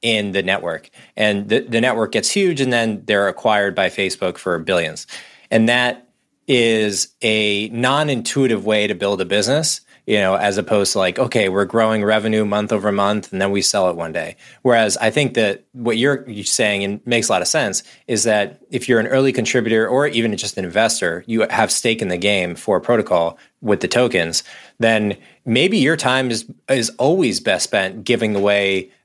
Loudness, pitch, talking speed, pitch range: -18 LUFS, 110 Hz, 195 wpm, 100-120 Hz